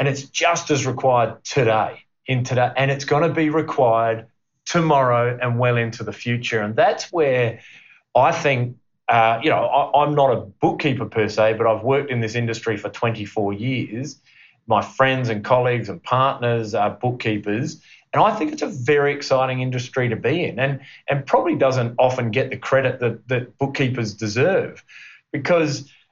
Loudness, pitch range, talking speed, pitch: -20 LUFS, 115-140 Hz, 175 wpm, 125 Hz